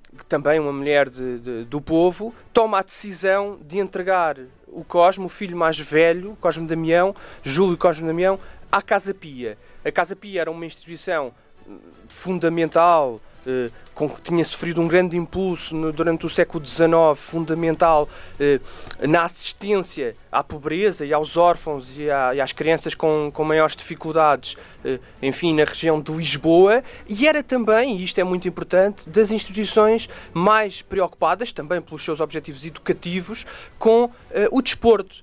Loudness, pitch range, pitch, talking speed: -20 LUFS, 155-190 Hz, 165 Hz, 155 wpm